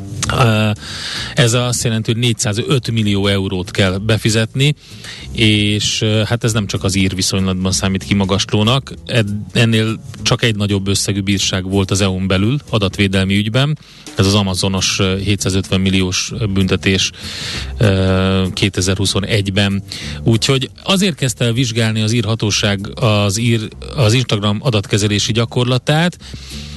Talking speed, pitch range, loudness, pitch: 115 wpm, 95-120 Hz, -15 LUFS, 105 Hz